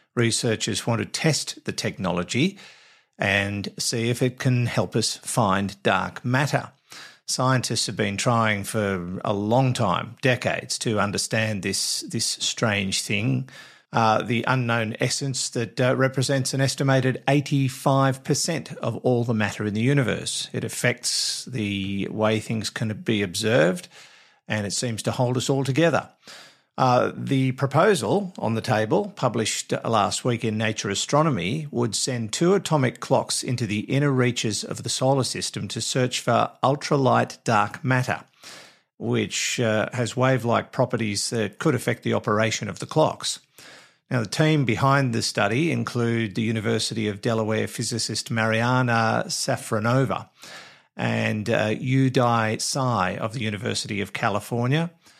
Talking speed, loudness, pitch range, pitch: 140 wpm, -23 LUFS, 110-130 Hz, 120 Hz